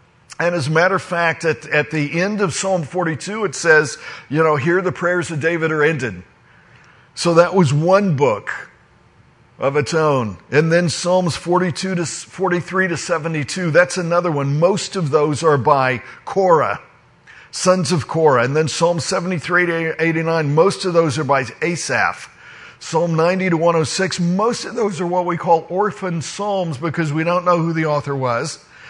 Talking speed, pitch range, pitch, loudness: 180 wpm, 150-180 Hz, 165 Hz, -18 LUFS